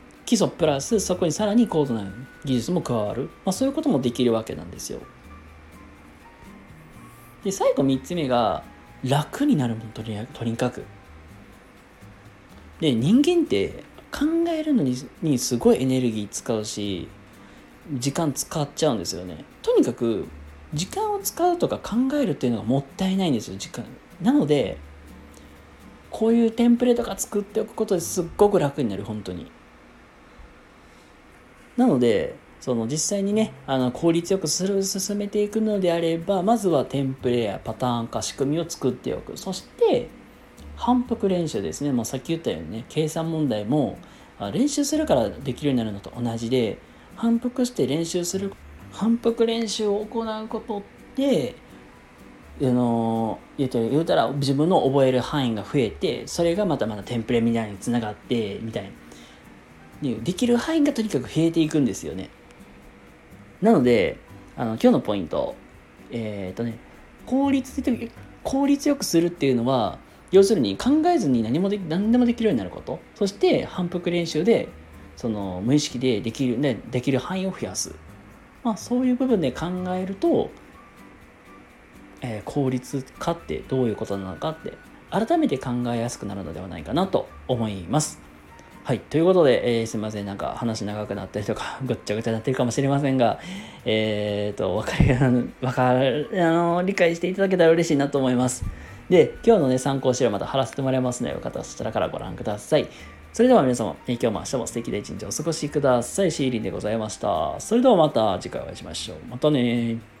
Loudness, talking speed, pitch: -23 LUFS, 345 characters per minute, 140 Hz